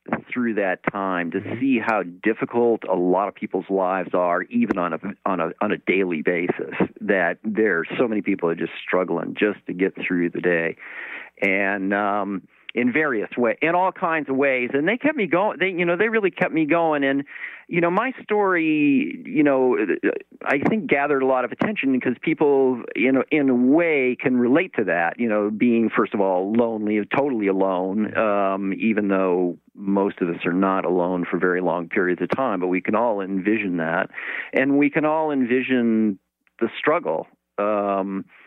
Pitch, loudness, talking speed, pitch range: 115 Hz, -22 LUFS, 190 wpm, 95-150 Hz